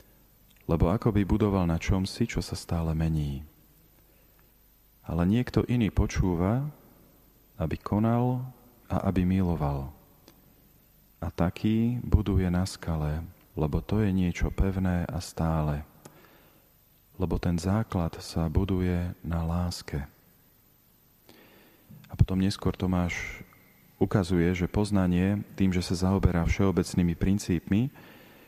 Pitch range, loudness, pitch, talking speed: 85-100 Hz, -28 LUFS, 90 Hz, 105 wpm